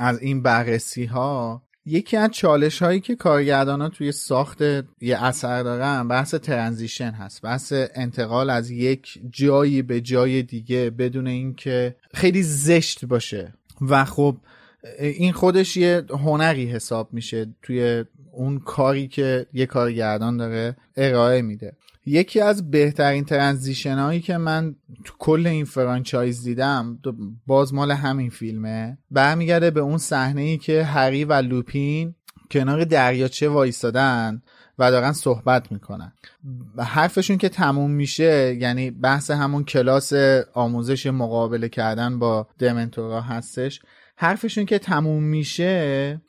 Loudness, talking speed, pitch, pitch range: -21 LUFS, 125 wpm, 135 Hz, 120-150 Hz